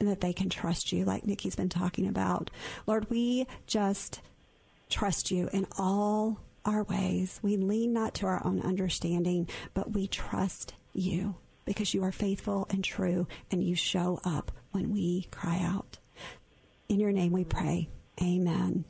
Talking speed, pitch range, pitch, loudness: 160 wpm, 180-205 Hz, 190 Hz, -31 LUFS